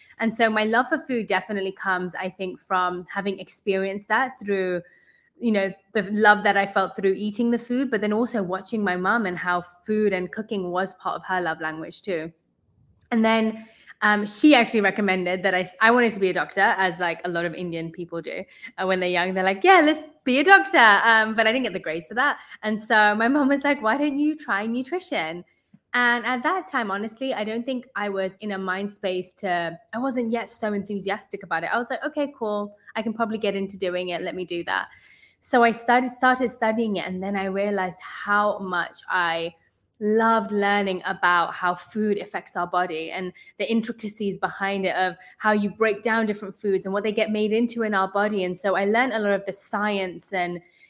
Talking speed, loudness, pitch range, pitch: 220 wpm, -23 LUFS, 185-225 Hz, 205 Hz